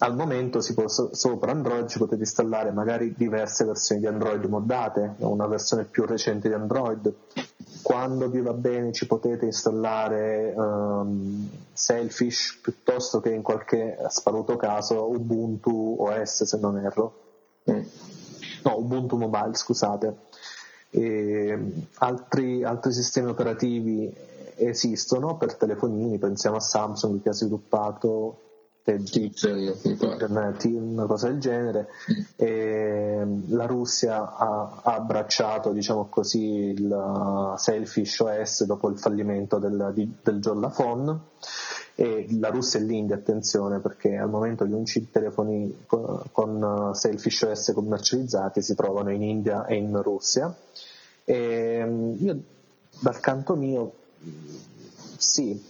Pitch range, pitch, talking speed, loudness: 105-115 Hz, 110 Hz, 115 wpm, -26 LUFS